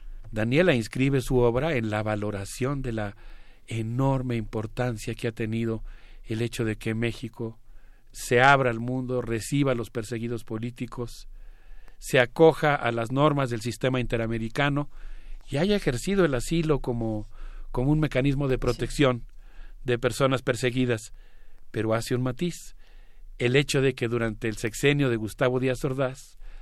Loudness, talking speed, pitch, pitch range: -26 LUFS, 145 wpm, 120 Hz, 115-135 Hz